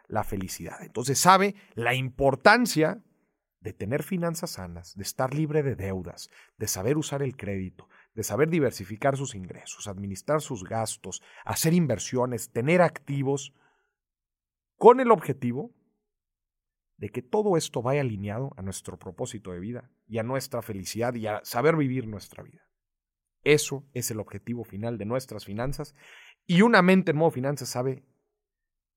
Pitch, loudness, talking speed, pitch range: 125 Hz, -26 LUFS, 145 wpm, 105-150 Hz